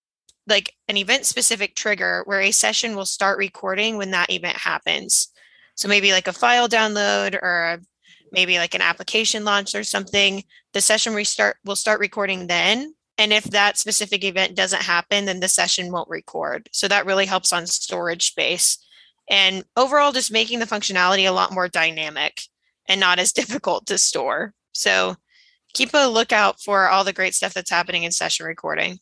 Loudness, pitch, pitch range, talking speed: -19 LUFS, 200 Hz, 180-215 Hz, 175 wpm